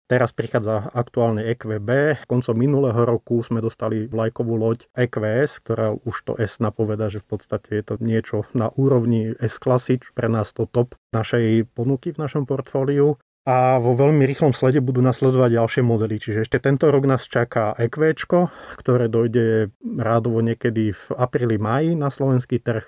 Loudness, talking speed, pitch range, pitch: -21 LUFS, 165 wpm, 110-130 Hz, 120 Hz